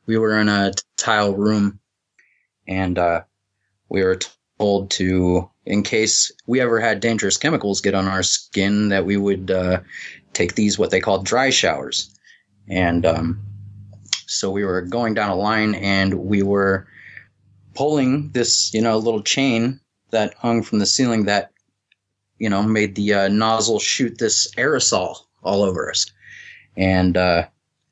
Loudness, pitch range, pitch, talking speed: -19 LUFS, 95-110 Hz, 100 Hz, 155 wpm